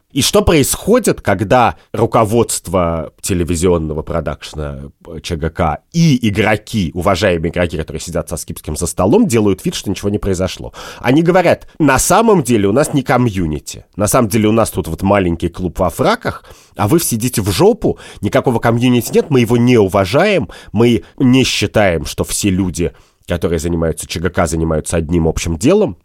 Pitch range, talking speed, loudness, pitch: 85-115 Hz, 160 wpm, -14 LUFS, 95 Hz